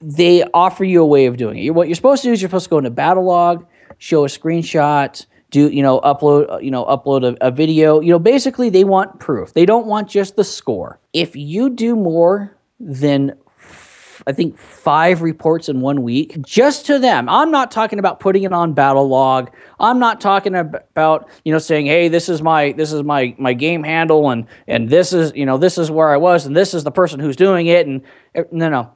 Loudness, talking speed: -14 LUFS, 230 wpm